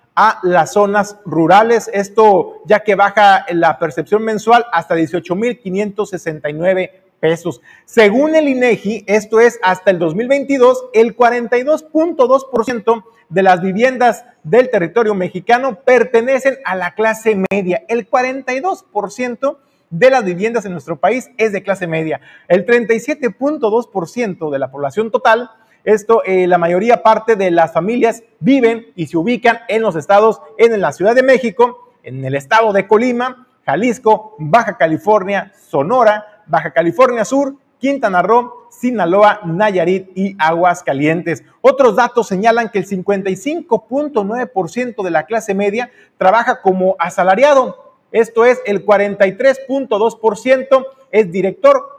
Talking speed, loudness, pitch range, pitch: 125 wpm, -14 LUFS, 185-245 Hz, 220 Hz